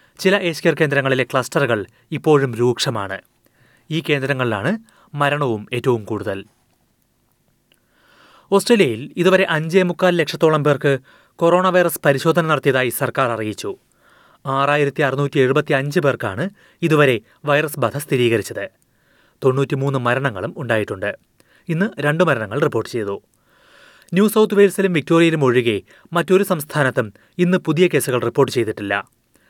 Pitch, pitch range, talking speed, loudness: 145 Hz, 125-170 Hz, 105 wpm, -18 LUFS